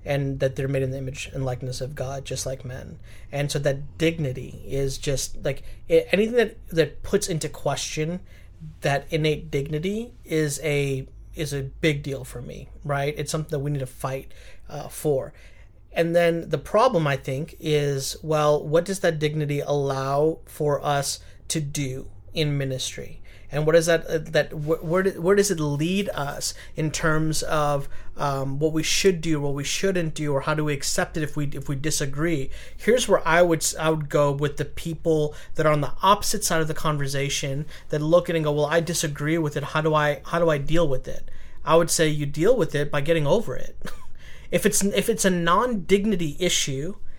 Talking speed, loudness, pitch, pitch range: 200 wpm, -24 LUFS, 150 Hz, 135-165 Hz